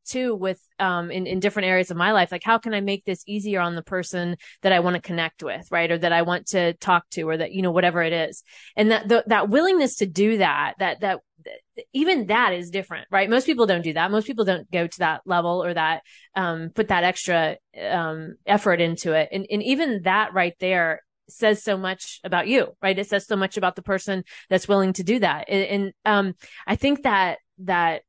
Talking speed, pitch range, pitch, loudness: 235 wpm, 175-210 Hz, 190 Hz, -22 LUFS